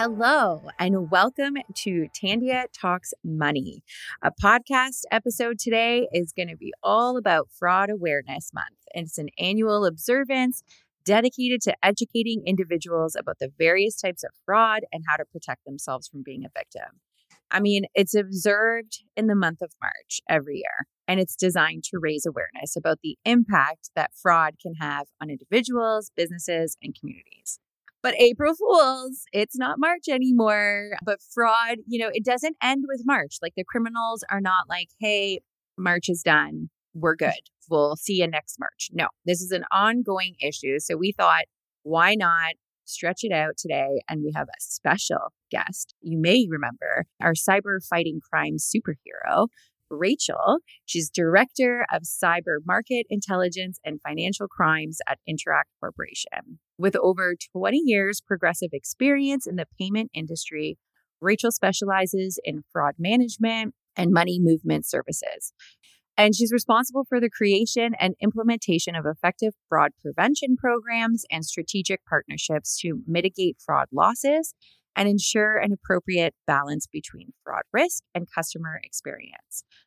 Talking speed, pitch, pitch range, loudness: 150 wpm, 190 Hz, 165-230 Hz, -24 LUFS